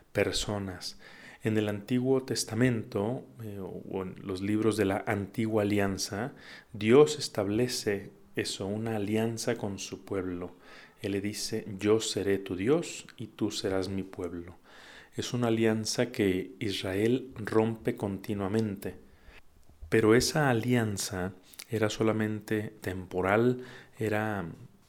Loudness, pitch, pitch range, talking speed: -30 LUFS, 105 Hz, 95-115 Hz, 115 wpm